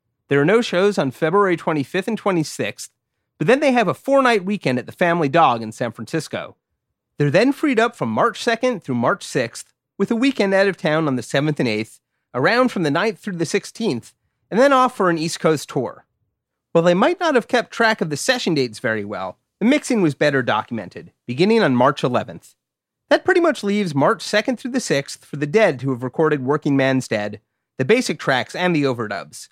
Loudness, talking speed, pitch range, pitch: -19 LUFS, 215 wpm, 135-225 Hz, 170 Hz